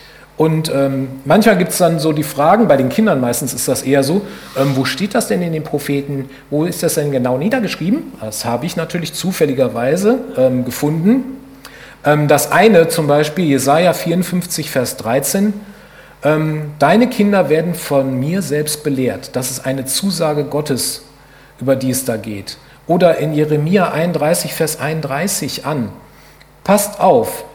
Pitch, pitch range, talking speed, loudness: 150 Hz, 135-175 Hz, 160 wpm, -15 LUFS